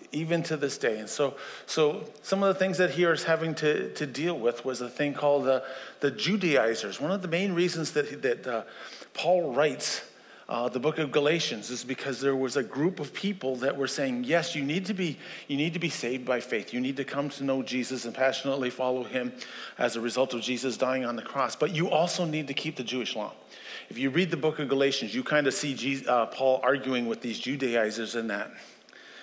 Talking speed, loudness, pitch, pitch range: 230 wpm, -29 LUFS, 140 Hz, 130-160 Hz